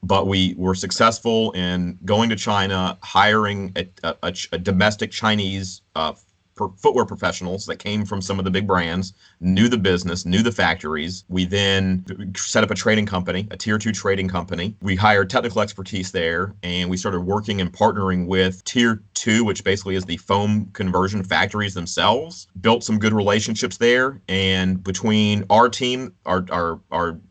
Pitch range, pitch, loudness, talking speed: 90-105 Hz, 95 Hz, -20 LUFS, 175 wpm